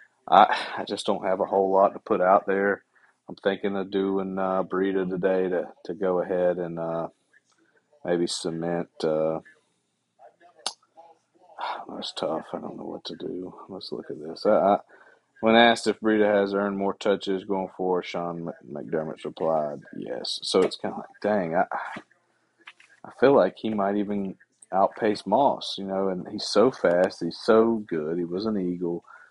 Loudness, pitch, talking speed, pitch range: -25 LUFS, 95 Hz, 170 wpm, 90-100 Hz